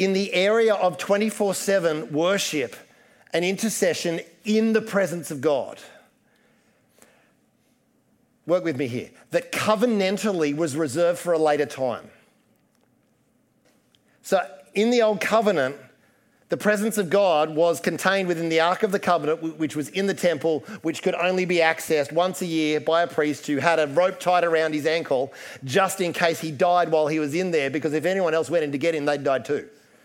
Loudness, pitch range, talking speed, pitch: -23 LUFS, 155-195 Hz, 175 wpm, 170 Hz